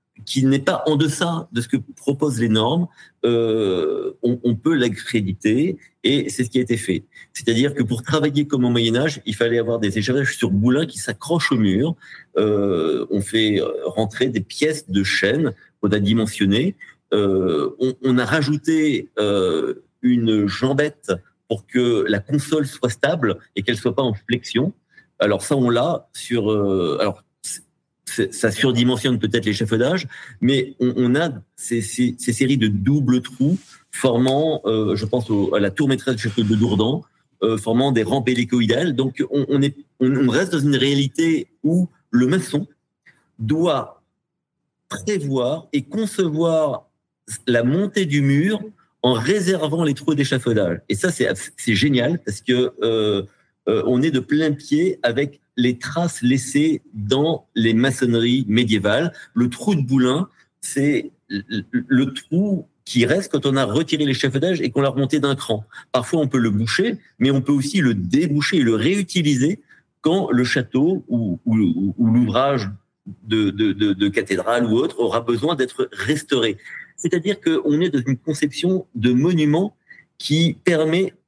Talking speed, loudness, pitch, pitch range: 165 wpm, -20 LUFS, 130 Hz, 115-155 Hz